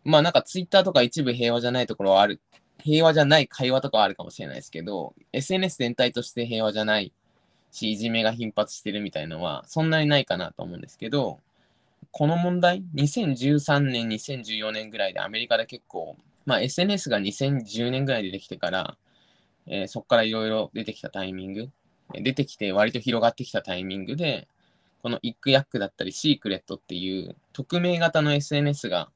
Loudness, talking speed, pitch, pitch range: -25 LUFS, 385 characters per minute, 125 Hz, 110-145 Hz